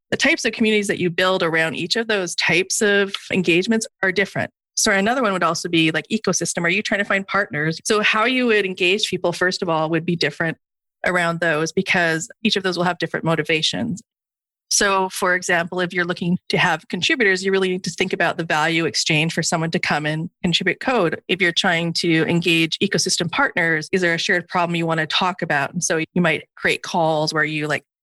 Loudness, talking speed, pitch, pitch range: -19 LUFS, 220 wpm, 180 Hz, 165-195 Hz